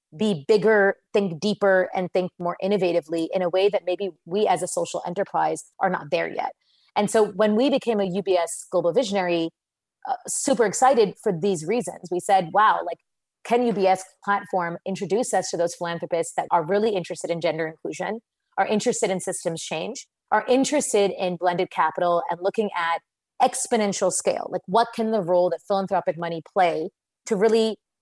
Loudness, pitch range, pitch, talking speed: -23 LUFS, 175-215 Hz, 190 Hz, 175 wpm